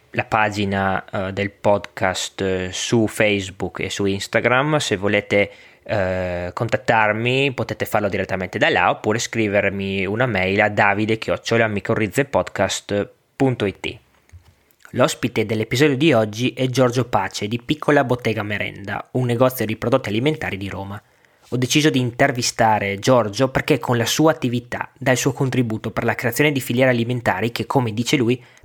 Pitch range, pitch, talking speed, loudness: 100-125 Hz, 115 Hz, 140 wpm, -20 LUFS